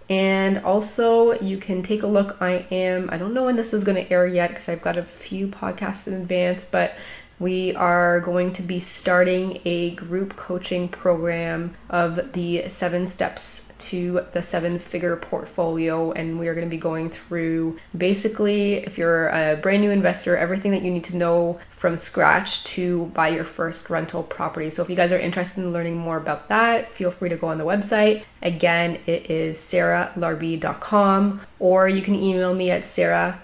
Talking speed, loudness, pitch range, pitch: 185 wpm, -22 LUFS, 170-190 Hz, 180 Hz